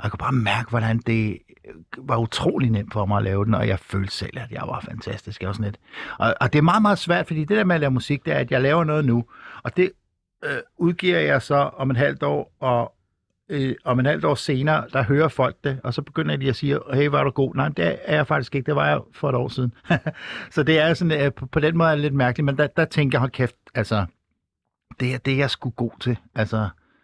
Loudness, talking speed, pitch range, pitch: -22 LUFS, 275 wpm, 115-150 Hz, 130 Hz